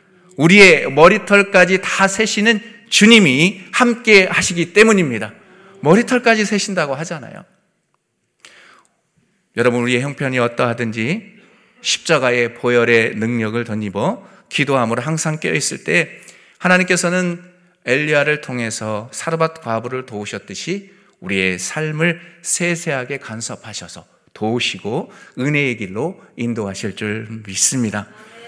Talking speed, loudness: 280 characters per minute, -15 LUFS